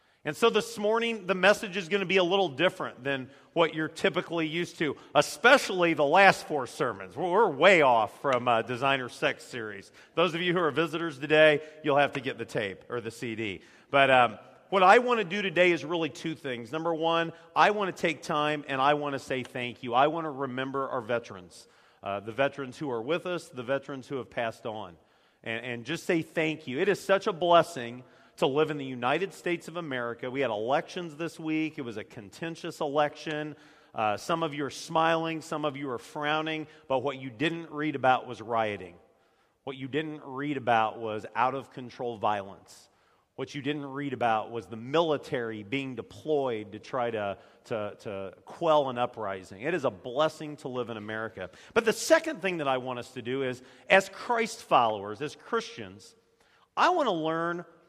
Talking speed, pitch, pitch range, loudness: 205 wpm, 150 Hz, 125-170 Hz, -28 LUFS